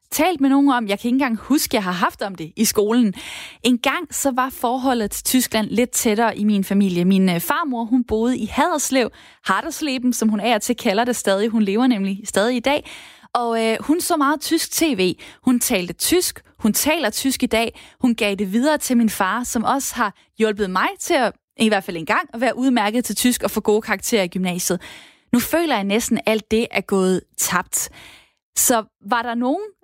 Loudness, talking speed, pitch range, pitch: -19 LUFS, 215 wpm, 210-265 Hz, 235 Hz